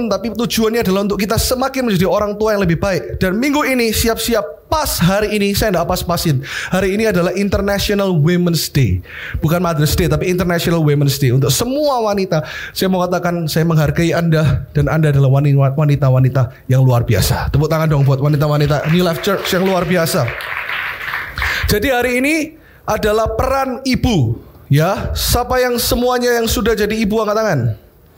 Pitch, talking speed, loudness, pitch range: 180 Hz, 165 wpm, -15 LUFS, 150-220 Hz